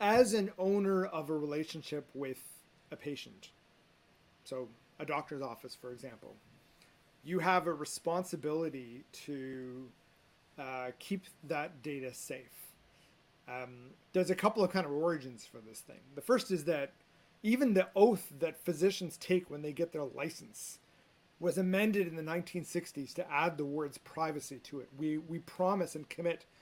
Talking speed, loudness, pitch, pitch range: 155 wpm, -36 LUFS, 160 Hz, 140-180 Hz